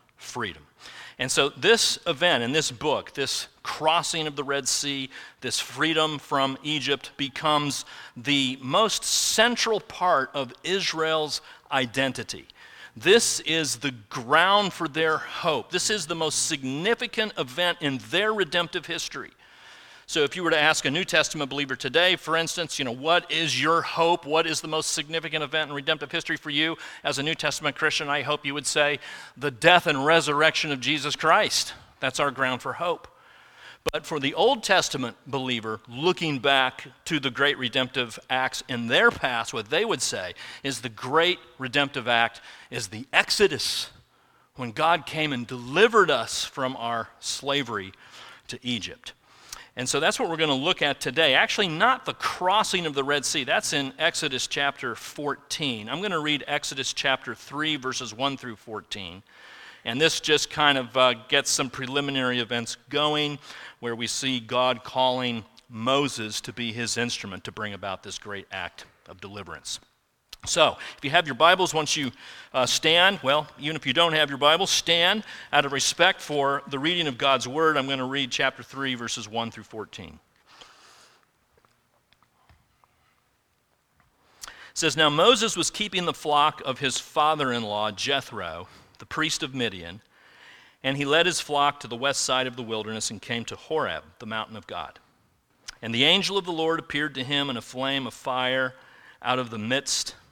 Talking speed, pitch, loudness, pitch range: 175 wpm, 140 Hz, -24 LUFS, 125-160 Hz